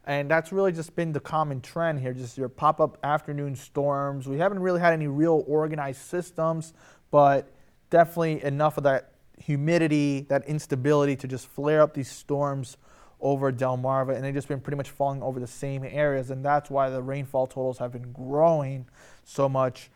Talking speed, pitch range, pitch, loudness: 185 wpm, 135-155 Hz, 140 Hz, -26 LUFS